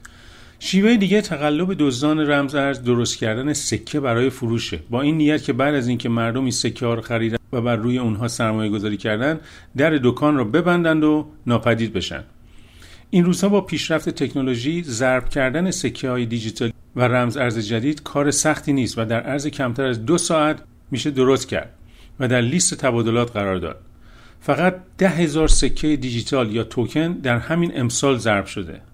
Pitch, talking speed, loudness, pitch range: 130 Hz, 175 wpm, -20 LUFS, 115-150 Hz